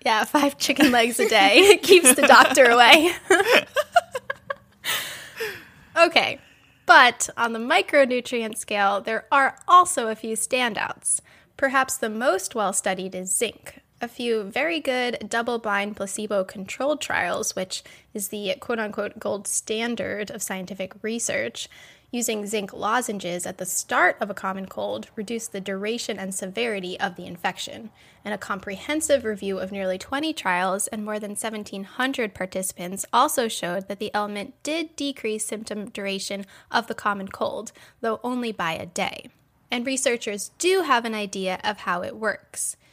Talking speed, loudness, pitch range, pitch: 145 wpm, -22 LUFS, 200-265 Hz, 225 Hz